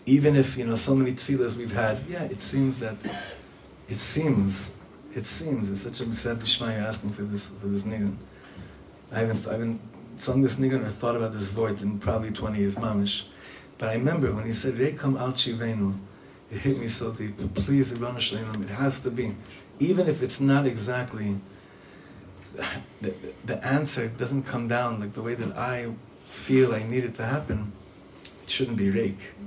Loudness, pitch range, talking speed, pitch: -27 LUFS, 100-130 Hz, 185 wpm, 115 Hz